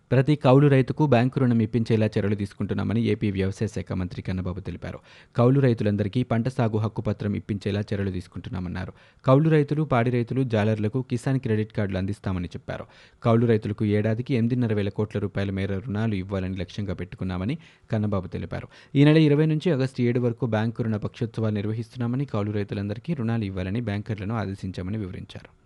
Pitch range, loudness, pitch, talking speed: 100-120 Hz, -25 LUFS, 110 Hz, 150 wpm